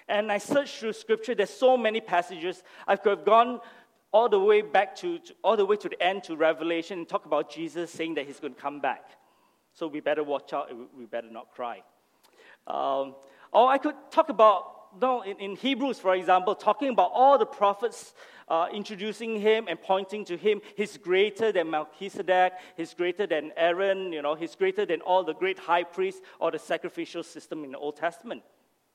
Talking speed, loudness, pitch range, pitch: 205 wpm, -27 LUFS, 165-225 Hz, 195 Hz